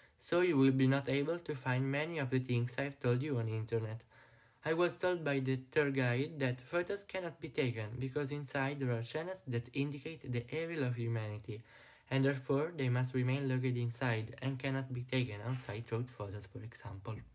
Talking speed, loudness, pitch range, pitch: 195 wpm, -37 LUFS, 120-145 Hz, 130 Hz